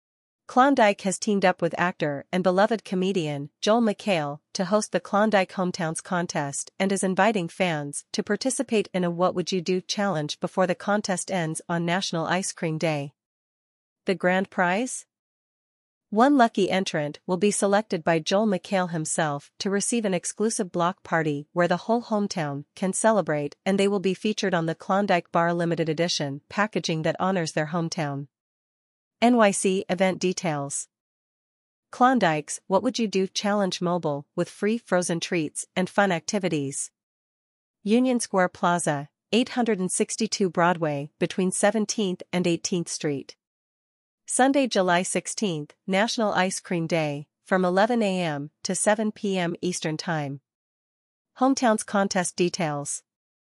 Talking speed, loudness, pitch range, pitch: 140 wpm, -25 LUFS, 165-205 Hz, 185 Hz